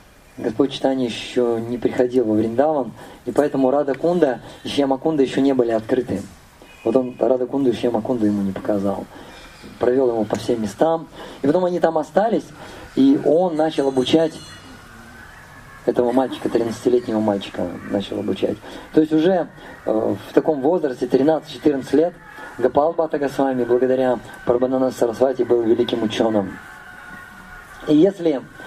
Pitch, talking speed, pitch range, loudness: 130 Hz, 130 wpm, 115-150 Hz, -20 LUFS